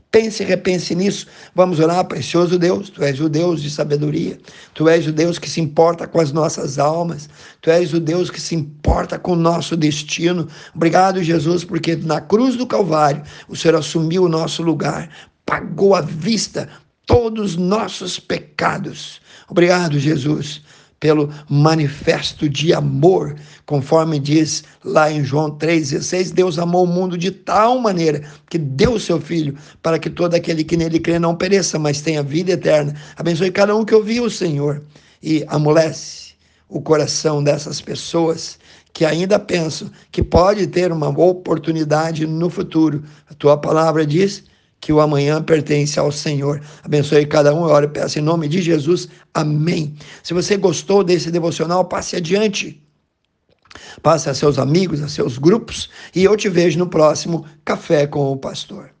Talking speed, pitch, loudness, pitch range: 165 wpm, 165 Hz, -17 LUFS, 150-180 Hz